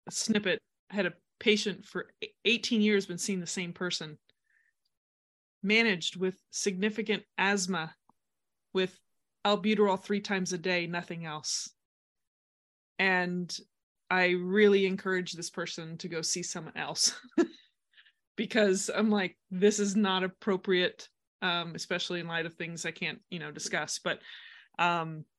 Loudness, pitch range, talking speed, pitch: -30 LUFS, 170-205 Hz, 135 wpm, 185 Hz